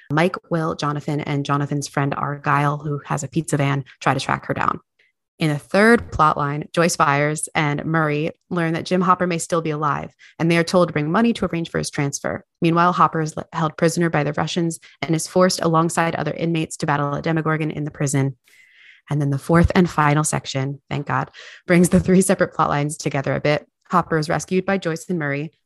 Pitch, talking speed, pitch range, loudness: 160 Hz, 215 wpm, 145-170 Hz, -20 LUFS